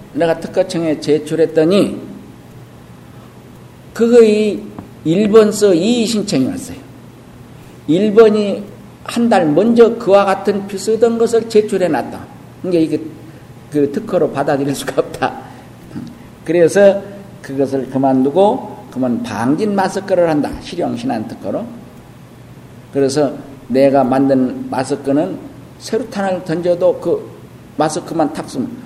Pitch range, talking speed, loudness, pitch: 140-215 Hz, 235 characters per minute, -15 LUFS, 180 Hz